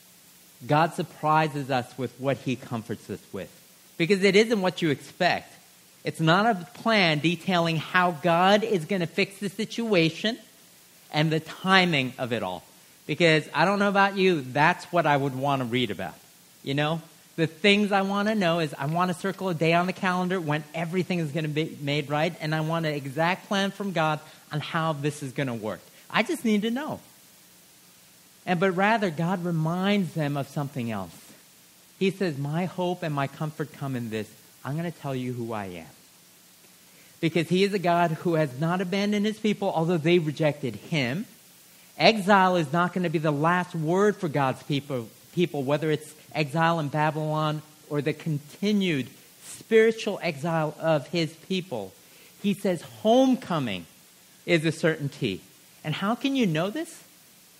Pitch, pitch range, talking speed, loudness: 165 Hz, 150-190 Hz, 180 wpm, -26 LUFS